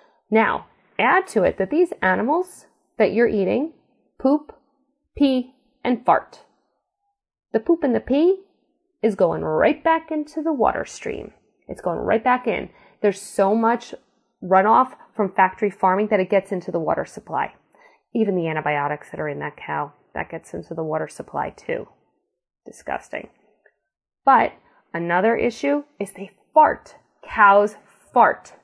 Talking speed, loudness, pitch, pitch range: 145 wpm, -21 LUFS, 230 Hz, 195-290 Hz